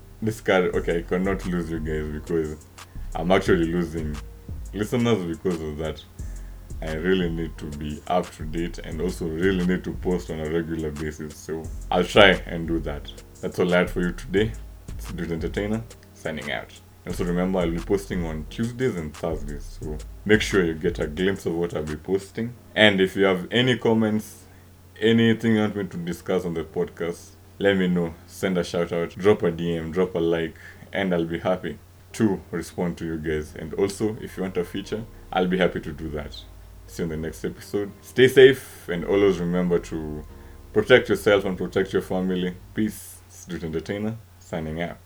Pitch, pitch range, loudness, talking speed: 90 Hz, 80-100 Hz, -24 LUFS, 195 wpm